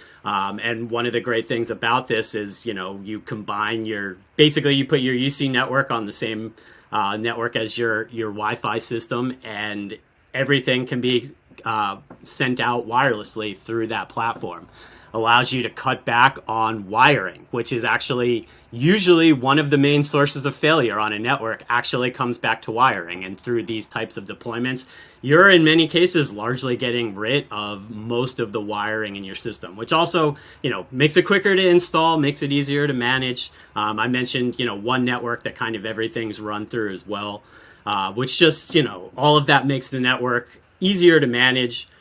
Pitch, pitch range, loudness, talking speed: 120 Hz, 110-140 Hz, -20 LUFS, 190 wpm